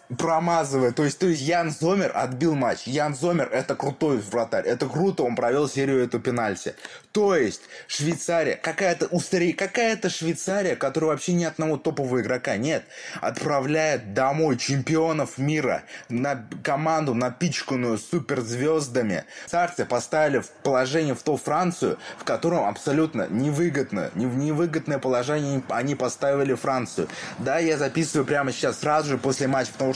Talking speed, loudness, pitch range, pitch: 140 wpm, -24 LUFS, 130-165 Hz, 145 Hz